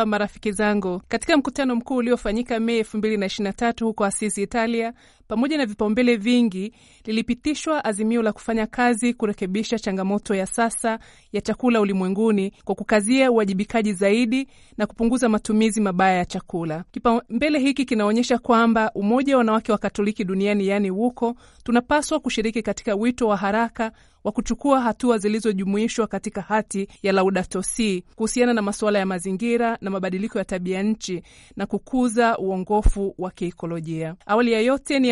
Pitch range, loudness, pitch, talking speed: 200-235 Hz, -22 LUFS, 220 Hz, 135 wpm